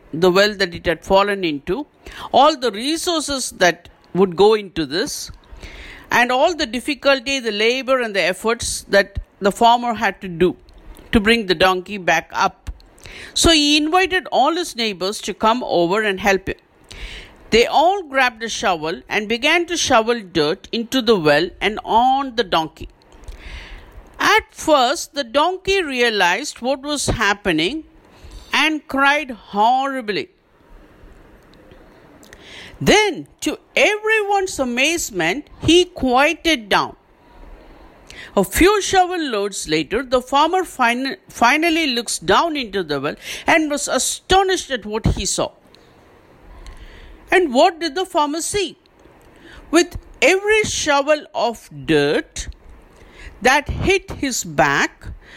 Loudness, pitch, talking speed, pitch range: -17 LUFS, 255 Hz, 130 wpm, 200-320 Hz